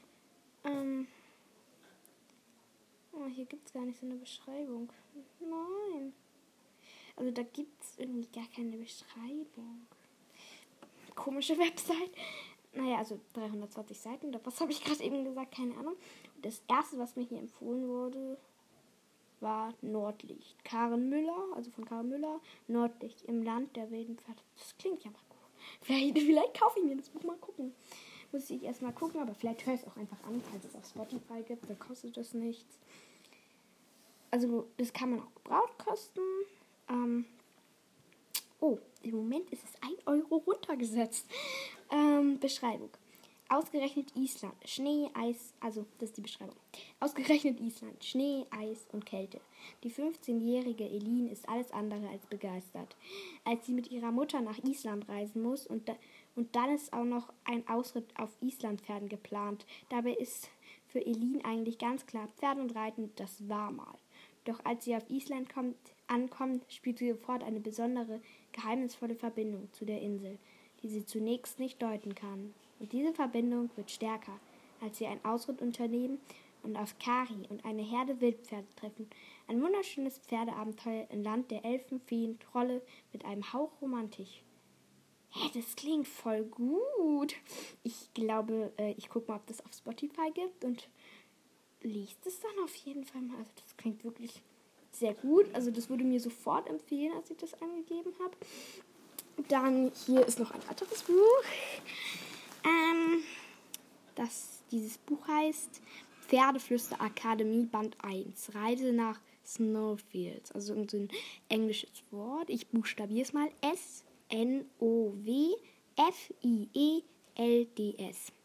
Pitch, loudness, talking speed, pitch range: 240 Hz, -36 LUFS, 145 wpm, 225-280 Hz